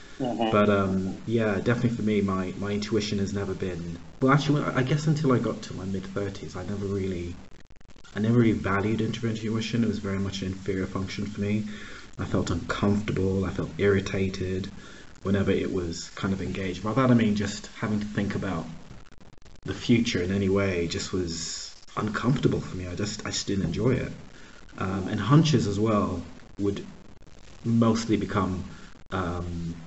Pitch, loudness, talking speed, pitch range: 100 Hz, -27 LUFS, 175 wpm, 95-110 Hz